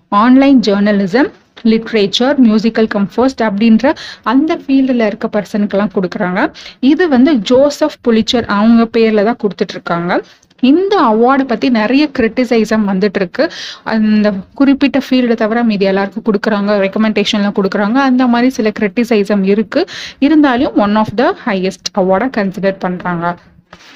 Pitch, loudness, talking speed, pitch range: 220 Hz, -12 LUFS, 120 wpm, 205-255 Hz